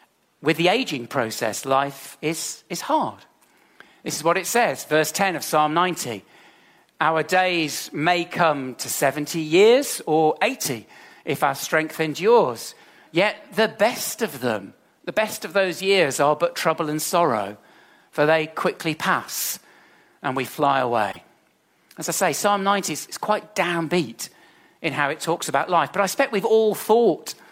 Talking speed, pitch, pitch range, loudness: 160 wpm, 160 Hz, 150-195 Hz, -22 LUFS